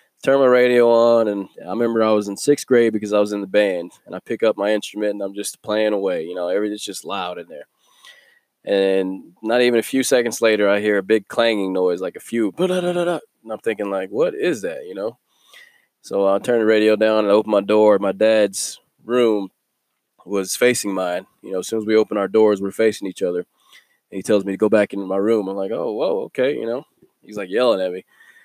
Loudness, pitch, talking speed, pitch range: -19 LUFS, 105 Hz, 240 wpm, 100-115 Hz